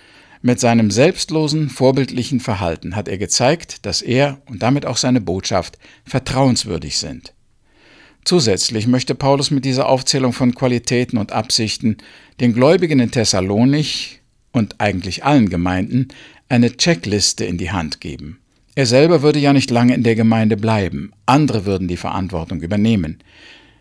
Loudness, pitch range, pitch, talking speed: -16 LUFS, 105-135 Hz, 120 Hz, 140 wpm